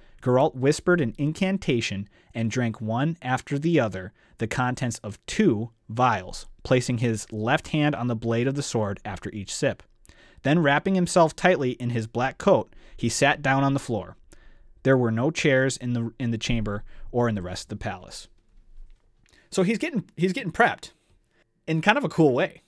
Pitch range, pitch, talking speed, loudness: 110-145 Hz, 120 Hz, 185 wpm, -25 LUFS